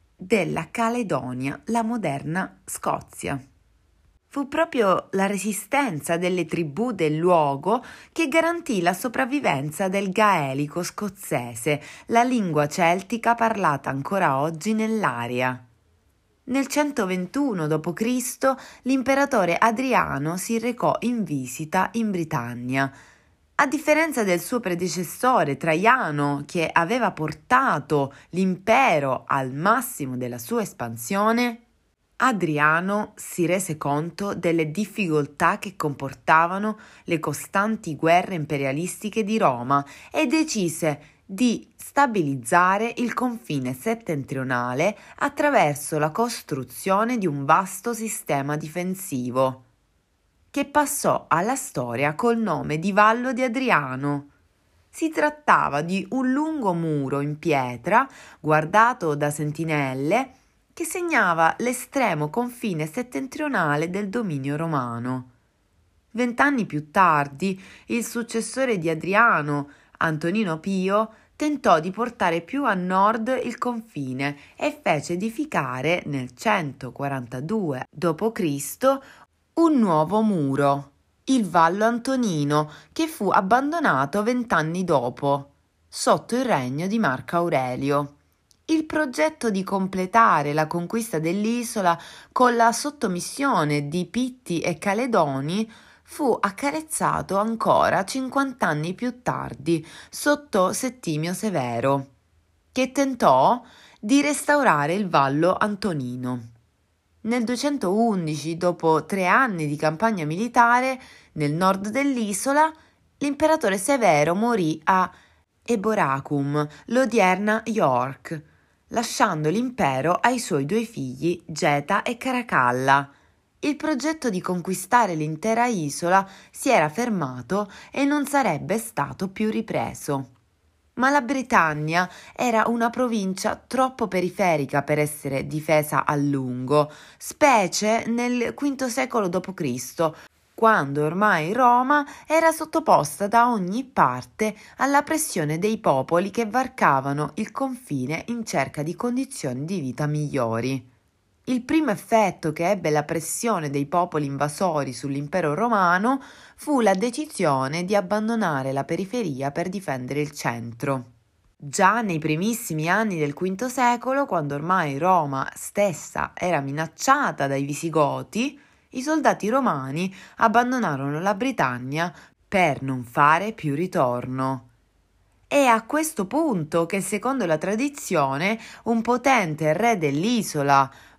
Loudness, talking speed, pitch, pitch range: -23 LUFS, 110 wpm, 185 Hz, 150-235 Hz